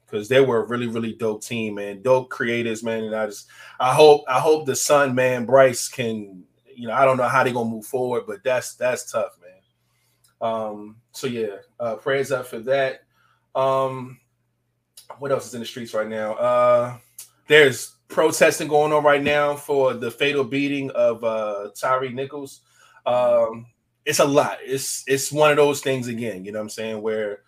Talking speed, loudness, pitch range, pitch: 190 wpm, -21 LUFS, 115-135 Hz, 125 Hz